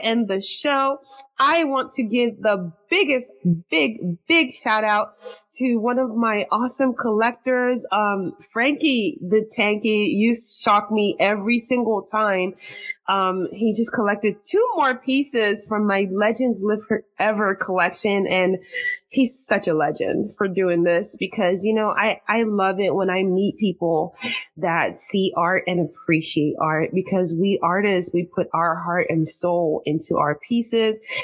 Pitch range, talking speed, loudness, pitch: 185-240 Hz, 150 wpm, -21 LUFS, 210 Hz